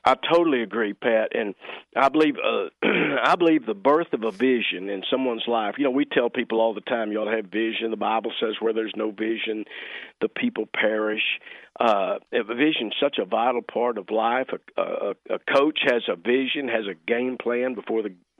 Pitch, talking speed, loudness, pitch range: 115 Hz, 210 wpm, -24 LUFS, 110-130 Hz